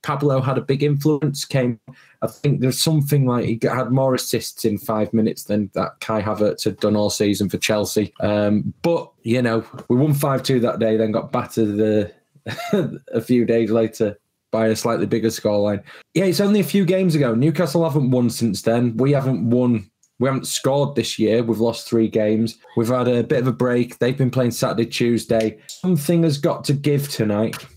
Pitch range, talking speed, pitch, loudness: 110-135 Hz, 200 wpm, 120 Hz, -20 LUFS